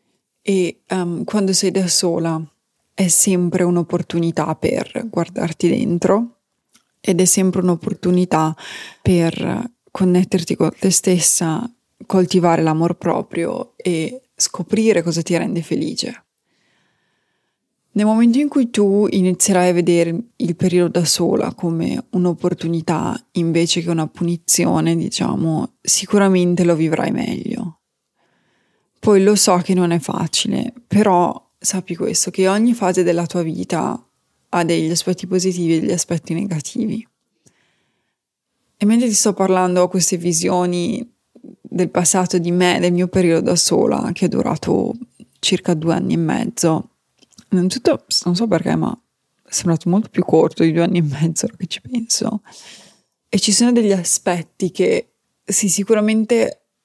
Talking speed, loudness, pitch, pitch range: 135 wpm, -17 LUFS, 185 Hz, 170-210 Hz